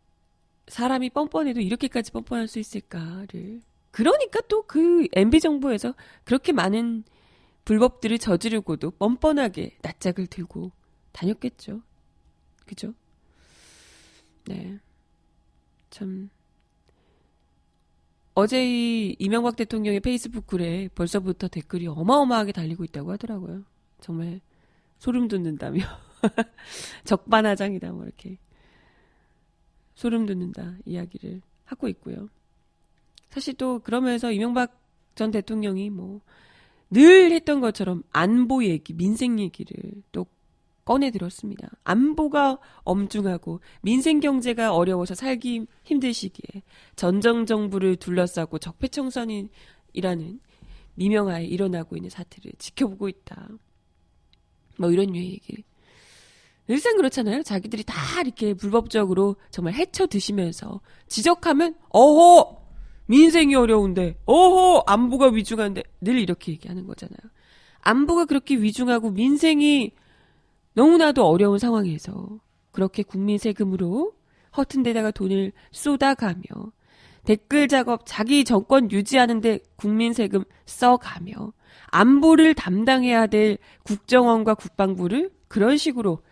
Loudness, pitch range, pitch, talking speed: -21 LUFS, 190-250 Hz, 215 Hz, 270 characters per minute